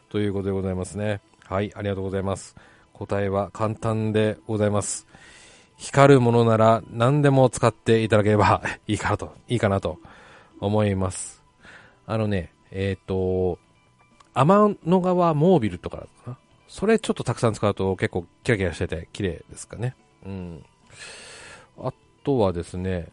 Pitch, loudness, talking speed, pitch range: 105 Hz, -23 LUFS, 305 characters per minute, 95-120 Hz